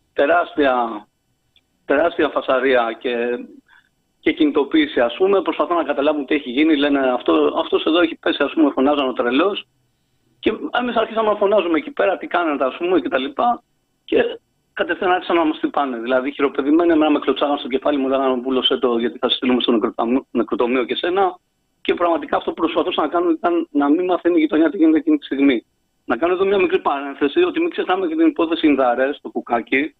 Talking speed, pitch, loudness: 195 wpm, 185 Hz, -18 LUFS